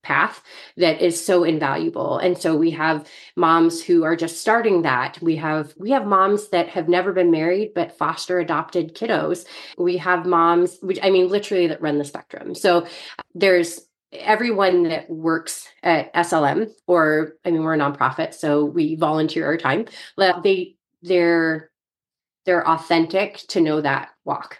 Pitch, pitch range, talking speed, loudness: 170 Hz, 160-180 Hz, 160 wpm, -20 LUFS